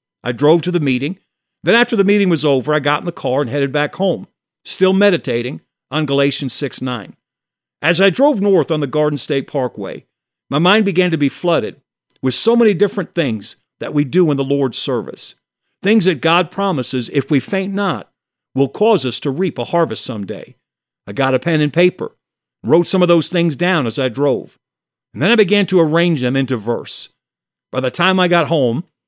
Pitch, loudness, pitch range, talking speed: 160 Hz, -16 LUFS, 135-185 Hz, 205 wpm